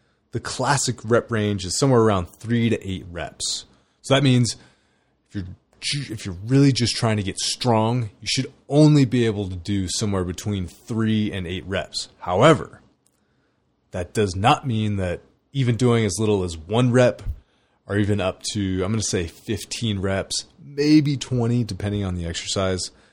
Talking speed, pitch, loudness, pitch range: 170 wpm, 105 Hz, -22 LUFS, 95-120 Hz